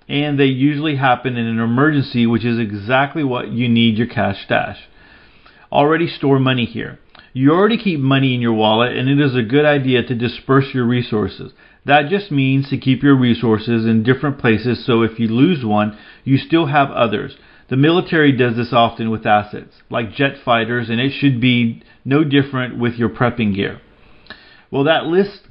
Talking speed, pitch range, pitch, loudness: 185 wpm, 115-140 Hz, 125 Hz, -16 LUFS